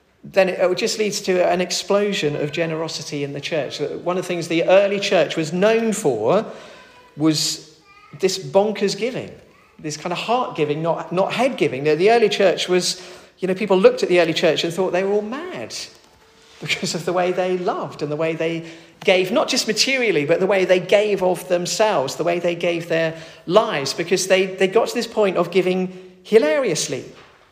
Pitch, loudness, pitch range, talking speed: 185 Hz, -19 LUFS, 165-205 Hz, 195 wpm